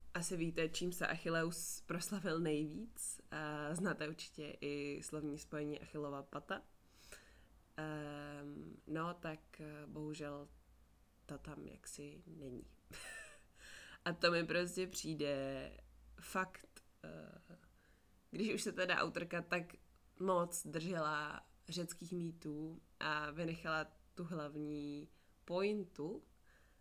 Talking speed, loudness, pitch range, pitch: 95 wpm, -43 LUFS, 145-175 Hz, 155 Hz